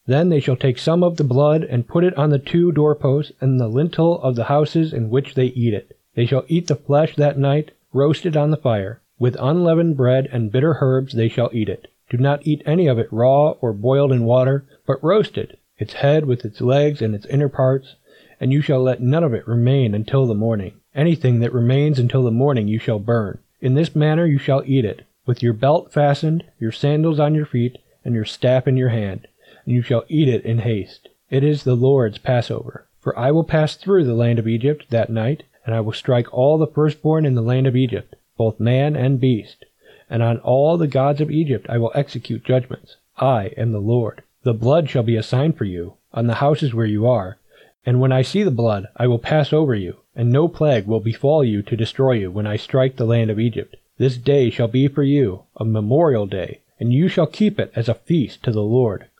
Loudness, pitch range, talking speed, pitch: -18 LUFS, 115-145 Hz, 230 wpm, 130 Hz